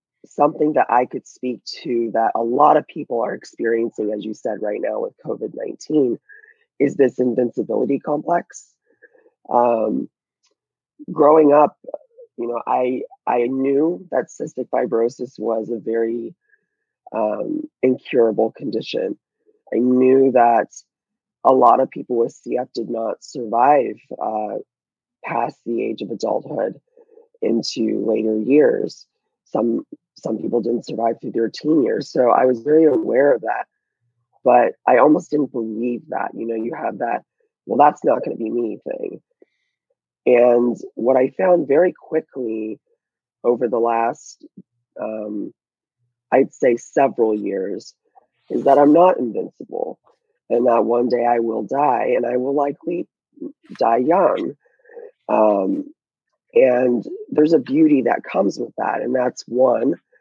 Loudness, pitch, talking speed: -19 LUFS, 145 Hz, 140 wpm